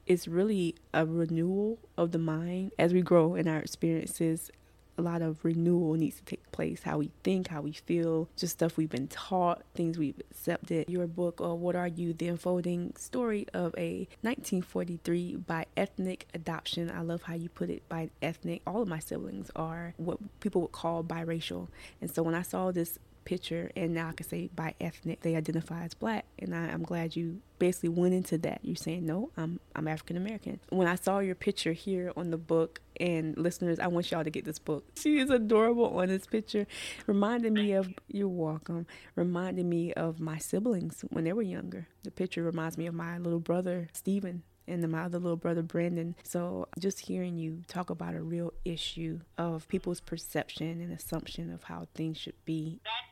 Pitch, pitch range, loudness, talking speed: 170 Hz, 165-180 Hz, -33 LUFS, 200 wpm